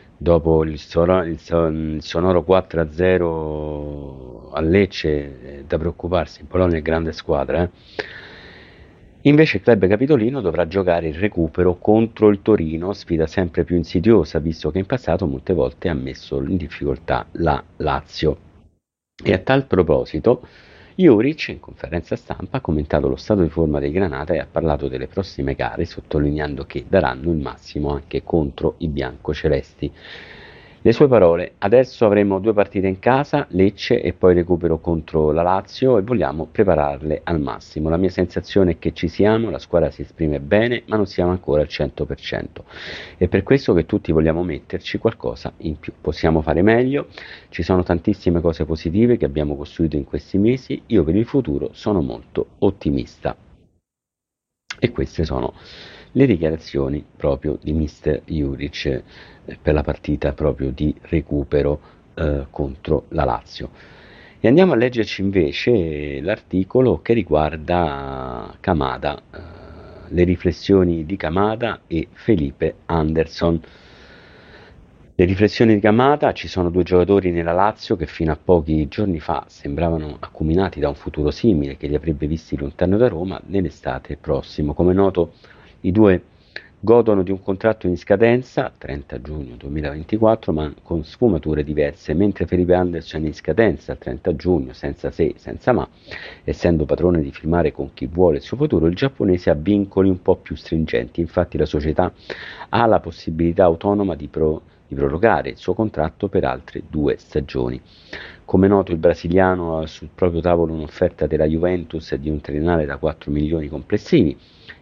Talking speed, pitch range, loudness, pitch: 150 wpm, 75-95 Hz, -19 LUFS, 85 Hz